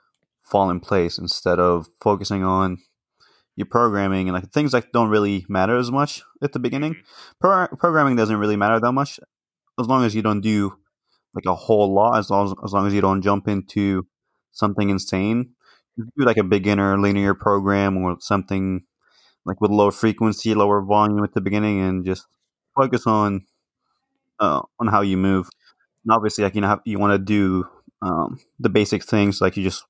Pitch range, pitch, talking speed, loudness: 95-110 Hz, 100 Hz, 190 wpm, -20 LUFS